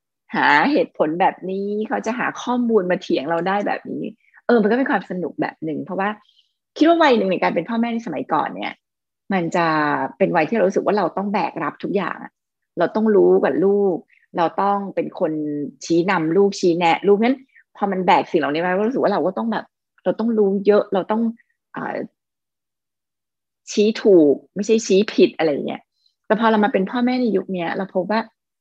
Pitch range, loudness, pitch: 180-225 Hz, -19 LUFS, 200 Hz